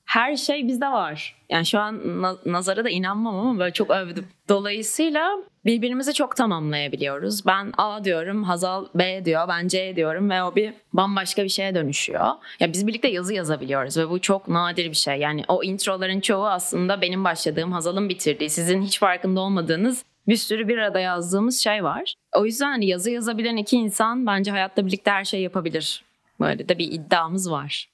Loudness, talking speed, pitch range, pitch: -23 LUFS, 175 wpm, 175-215 Hz, 190 Hz